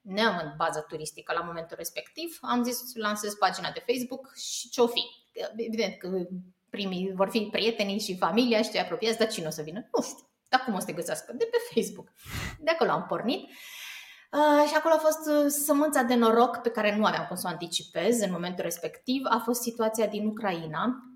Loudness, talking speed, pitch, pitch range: -28 LUFS, 205 wpm, 225 Hz, 190-245 Hz